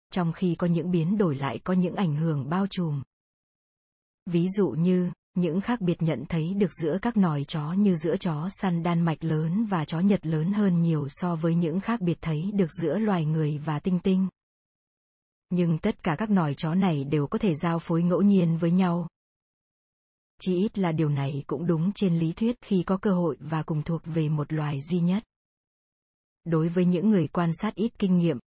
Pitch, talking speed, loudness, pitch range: 175 Hz, 210 wpm, -26 LUFS, 160-190 Hz